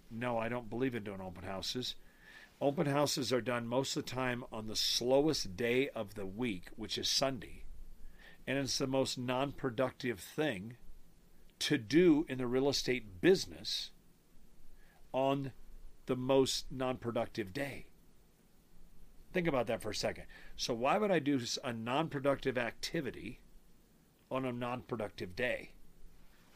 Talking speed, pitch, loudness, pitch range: 150 wpm, 125 Hz, -35 LUFS, 115-135 Hz